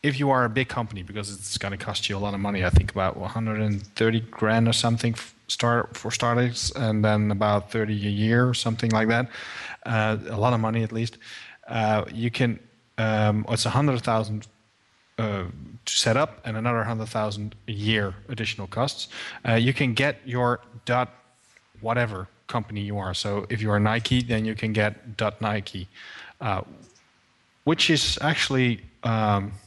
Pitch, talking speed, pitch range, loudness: 110 Hz, 180 wpm, 105-120 Hz, -25 LUFS